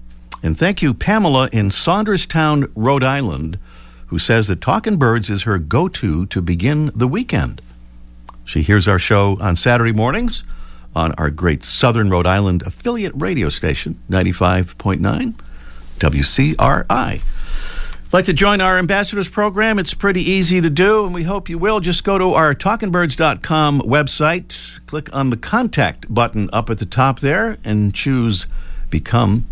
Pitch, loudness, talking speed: 120 Hz, -16 LUFS, 150 wpm